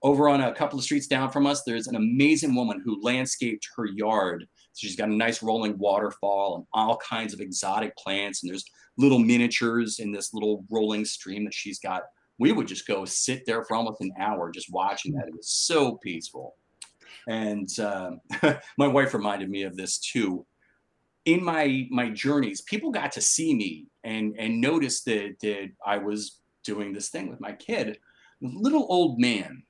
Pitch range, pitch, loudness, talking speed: 105-140 Hz, 115 Hz, -26 LUFS, 185 wpm